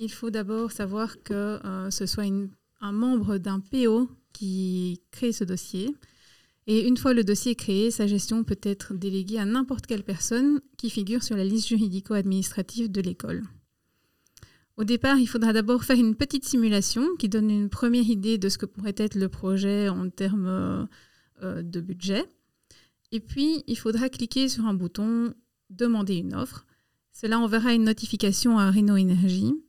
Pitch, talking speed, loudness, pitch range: 215 Hz, 170 wpm, -26 LUFS, 195-235 Hz